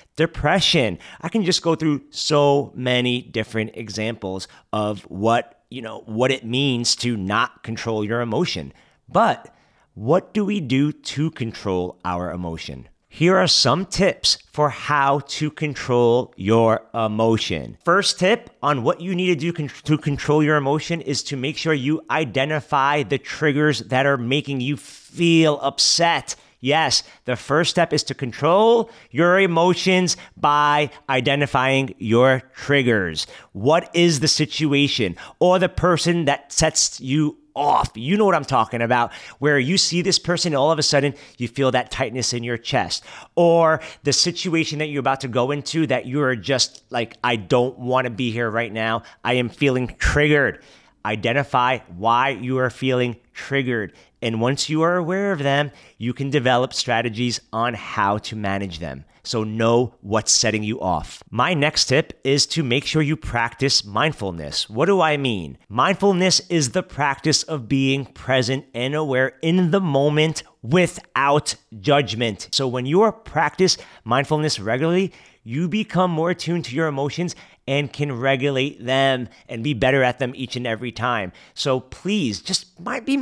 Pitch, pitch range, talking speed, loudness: 135 Hz, 120-155 Hz, 165 wpm, -20 LUFS